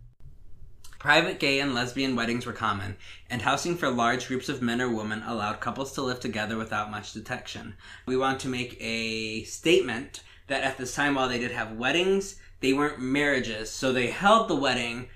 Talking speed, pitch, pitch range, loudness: 185 wpm, 125 Hz, 110-135 Hz, -27 LUFS